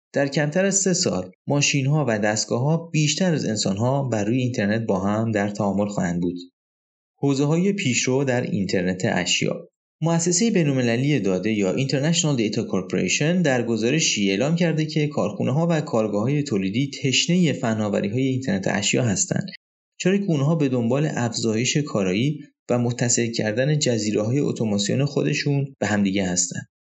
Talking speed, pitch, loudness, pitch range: 155 wpm, 130 Hz, -22 LUFS, 105-150 Hz